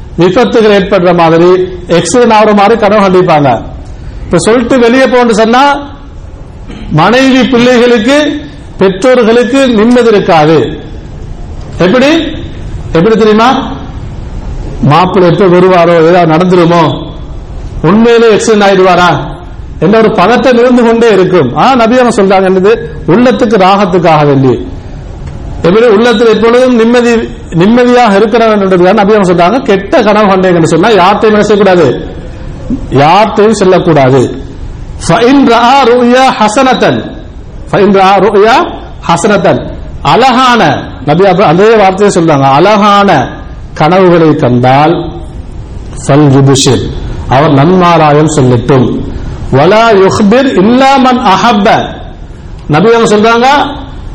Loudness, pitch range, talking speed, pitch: -5 LUFS, 170-235 Hz, 95 wpm, 200 Hz